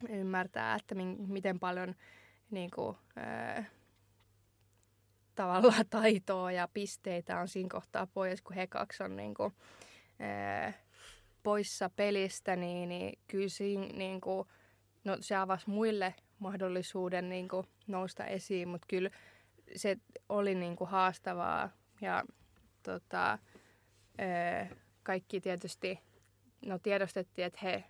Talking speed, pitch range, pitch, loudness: 120 wpm, 175-195 Hz, 185 Hz, -37 LUFS